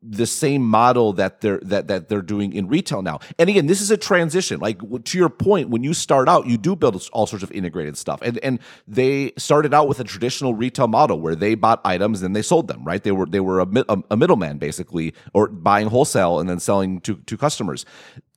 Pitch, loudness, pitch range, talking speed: 115 Hz, -19 LUFS, 100-140 Hz, 230 wpm